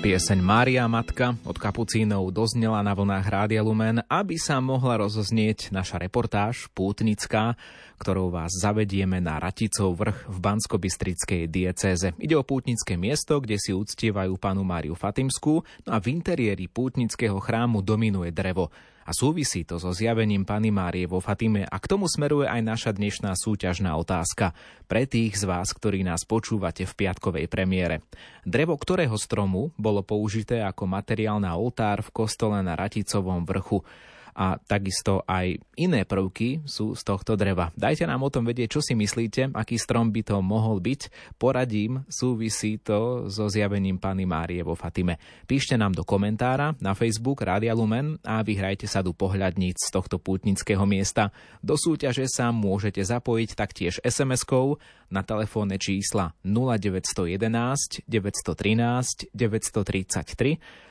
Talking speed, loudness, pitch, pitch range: 145 wpm, -26 LUFS, 105 Hz, 95-115 Hz